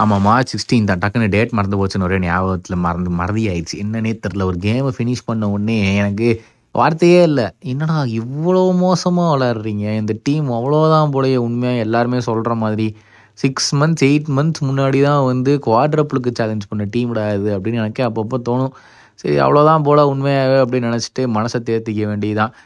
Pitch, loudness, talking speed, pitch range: 115 Hz, -16 LUFS, 160 wpm, 105-135 Hz